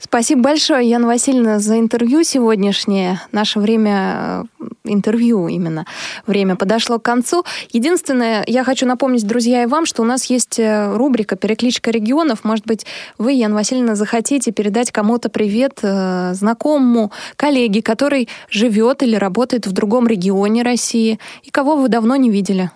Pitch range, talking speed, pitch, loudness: 215-255 Hz, 140 wpm, 235 Hz, -15 LUFS